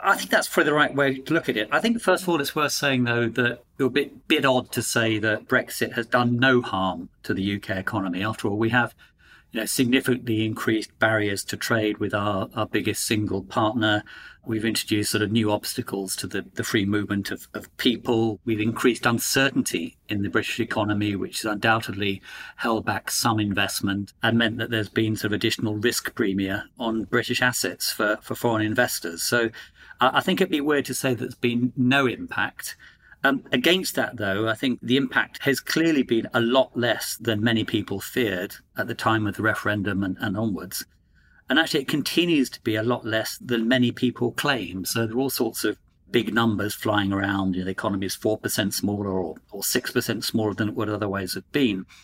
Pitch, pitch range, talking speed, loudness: 110 Hz, 105-125 Hz, 205 wpm, -24 LUFS